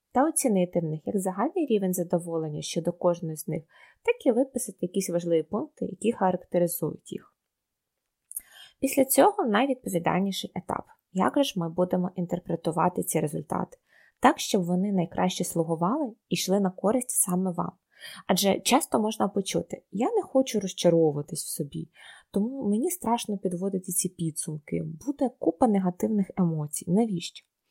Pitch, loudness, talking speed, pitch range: 185 Hz, -27 LUFS, 140 wpm, 175-230 Hz